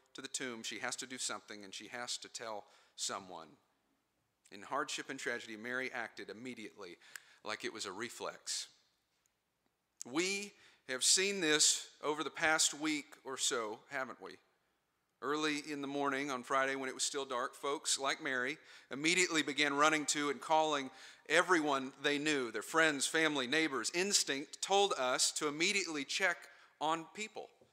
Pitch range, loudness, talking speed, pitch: 130-155 Hz, -35 LUFS, 160 wpm, 145 Hz